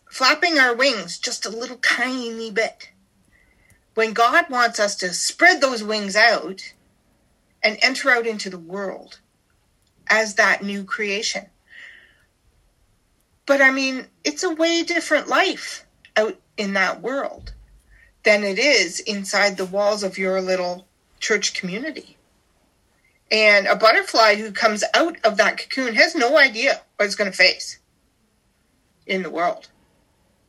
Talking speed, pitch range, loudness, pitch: 140 wpm, 195-270 Hz, -19 LUFS, 220 Hz